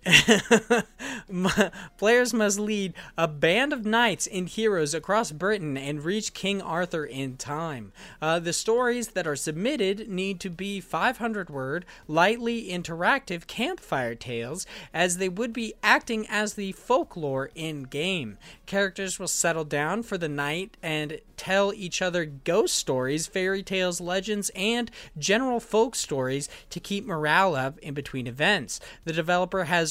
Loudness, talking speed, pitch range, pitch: -26 LUFS, 145 wpm, 155-210 Hz, 185 Hz